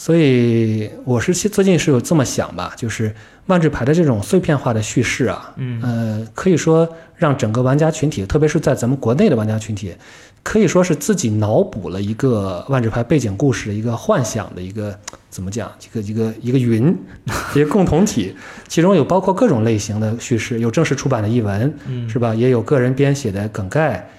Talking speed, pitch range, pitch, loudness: 305 characters per minute, 110-155 Hz, 125 Hz, -17 LUFS